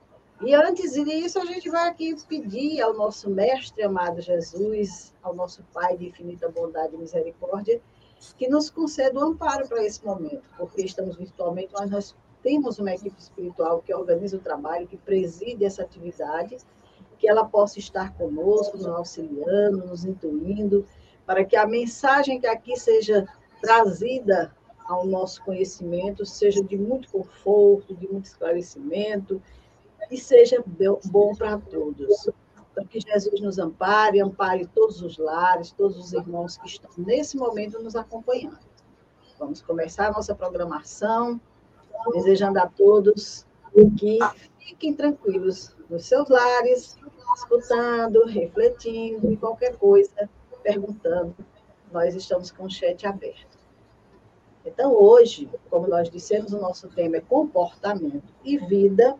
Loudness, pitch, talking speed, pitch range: -23 LUFS, 205 Hz, 135 wpm, 185-255 Hz